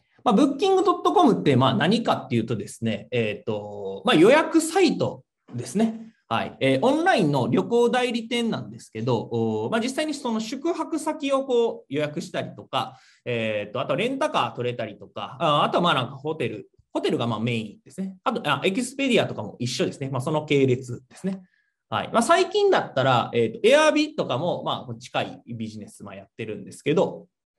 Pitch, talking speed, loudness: 175 Hz, 390 characters per minute, -23 LUFS